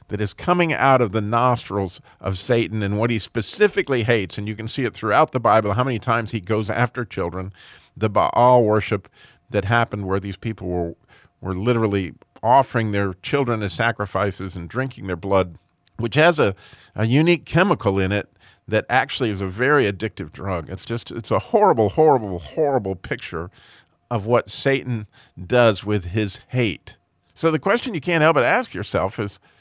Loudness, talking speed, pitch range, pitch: -21 LUFS, 180 wpm, 95-125 Hz, 110 Hz